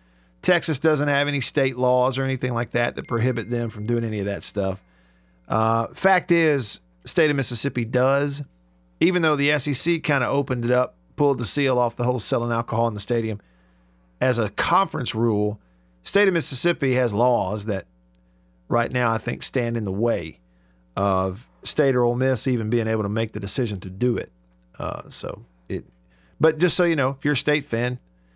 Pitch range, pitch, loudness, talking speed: 95-135 Hz, 120 Hz, -22 LUFS, 195 wpm